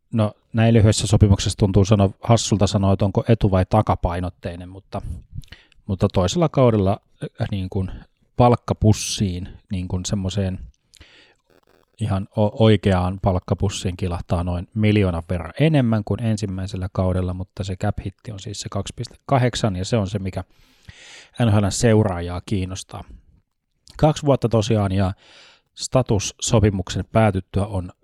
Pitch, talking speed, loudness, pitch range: 100 Hz, 120 wpm, -20 LUFS, 95-110 Hz